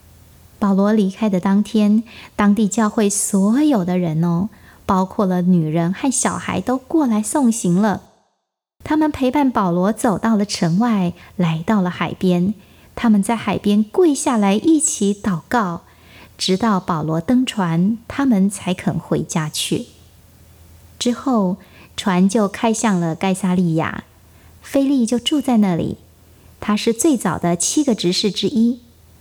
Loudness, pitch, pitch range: -18 LUFS, 200 Hz, 175-230 Hz